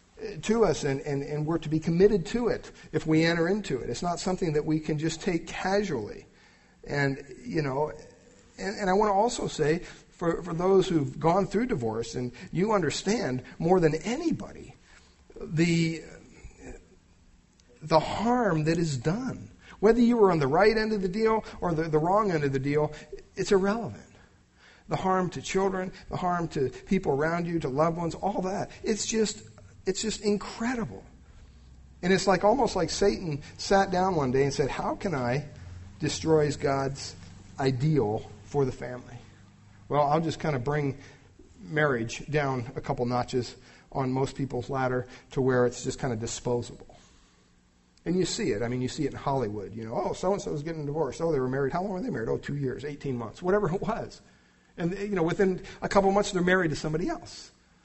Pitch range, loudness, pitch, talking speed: 130-190 Hz, -28 LUFS, 155 Hz, 200 wpm